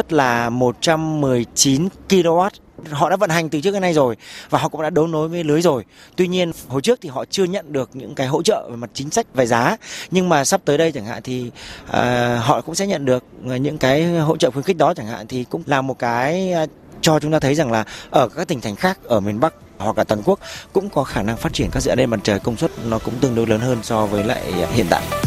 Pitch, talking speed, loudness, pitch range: 145 Hz, 260 wpm, -19 LUFS, 120-170 Hz